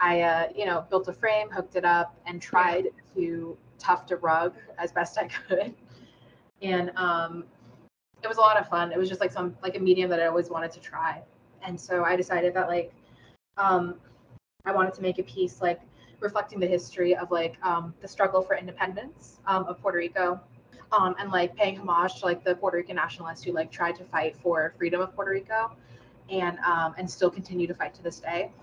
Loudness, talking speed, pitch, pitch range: -27 LUFS, 210 wpm, 180 Hz, 170-185 Hz